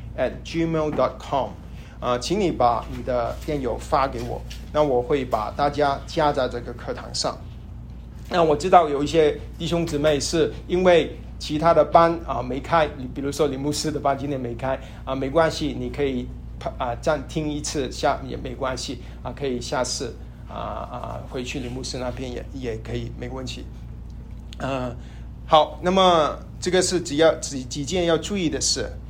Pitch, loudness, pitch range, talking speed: 140 Hz, -23 LUFS, 125-160 Hz, 260 characters per minute